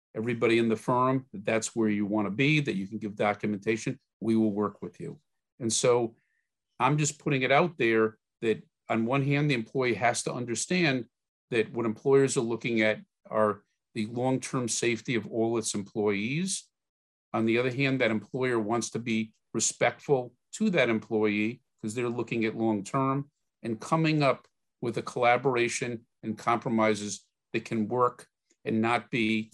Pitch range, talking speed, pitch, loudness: 110-130 Hz, 175 wpm, 115 Hz, -28 LUFS